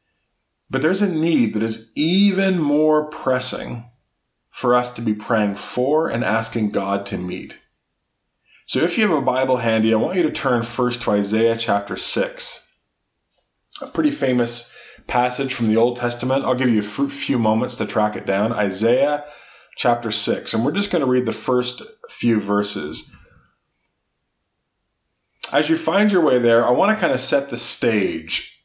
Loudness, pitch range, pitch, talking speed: -19 LUFS, 110-145 Hz, 125 Hz, 170 wpm